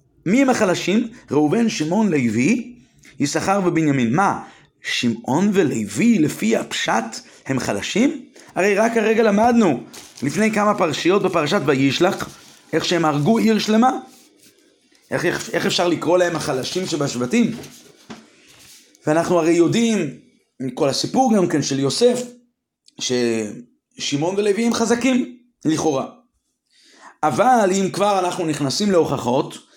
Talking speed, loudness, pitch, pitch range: 115 wpm, -19 LUFS, 190 Hz, 155-230 Hz